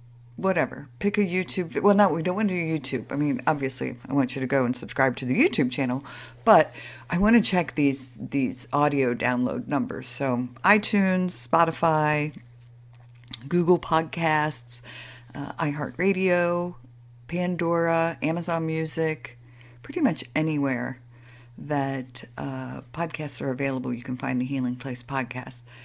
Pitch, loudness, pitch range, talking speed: 140 Hz, -25 LUFS, 125-165 Hz, 140 wpm